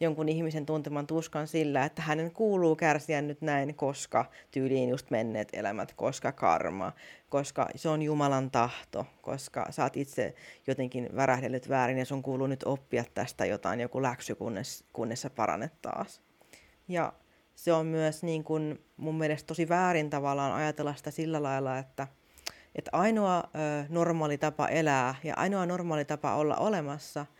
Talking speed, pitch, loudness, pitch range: 155 wpm, 150 Hz, -31 LUFS, 135-160 Hz